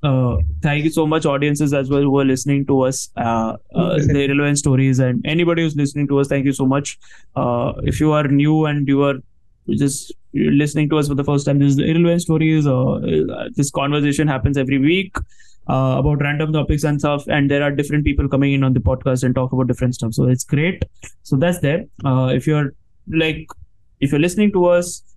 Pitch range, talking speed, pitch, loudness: 130-150 Hz, 215 wpm, 140 Hz, -18 LUFS